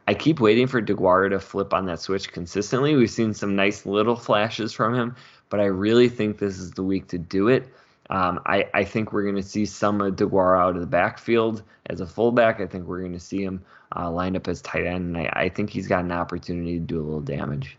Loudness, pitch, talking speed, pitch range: -23 LUFS, 95 Hz, 250 wpm, 90-105 Hz